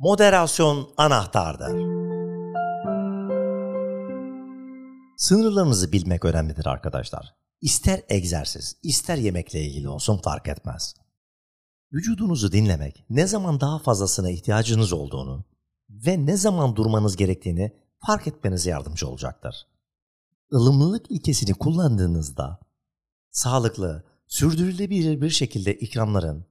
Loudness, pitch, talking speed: -23 LUFS, 110 Hz, 90 wpm